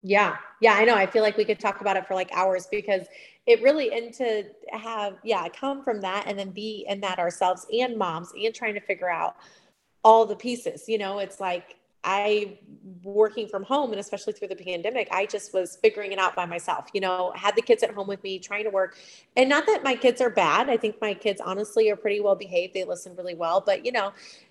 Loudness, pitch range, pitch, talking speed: -25 LUFS, 190-225 Hz, 205 Hz, 240 wpm